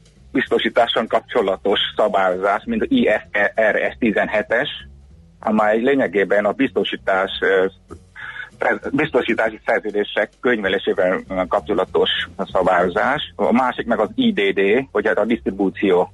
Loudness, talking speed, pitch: -19 LUFS, 95 wpm, 105 Hz